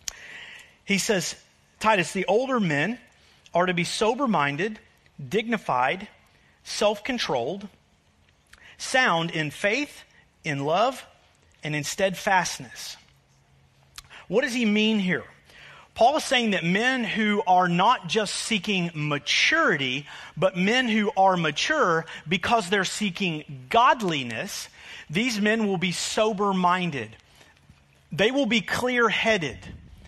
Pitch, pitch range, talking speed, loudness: 190 Hz, 155-220 Hz, 115 wpm, -24 LUFS